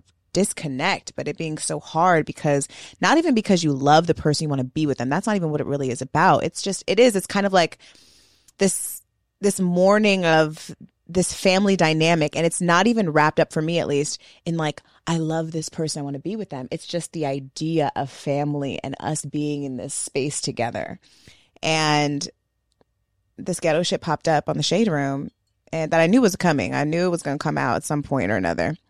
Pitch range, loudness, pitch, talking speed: 145-175 Hz, -22 LUFS, 155 Hz, 220 wpm